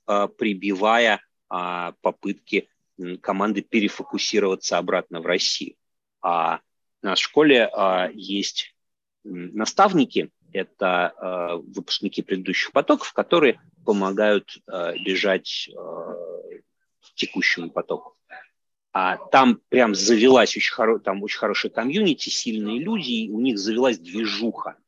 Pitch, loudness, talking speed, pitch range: 105 Hz, -22 LUFS, 95 wpm, 95-135 Hz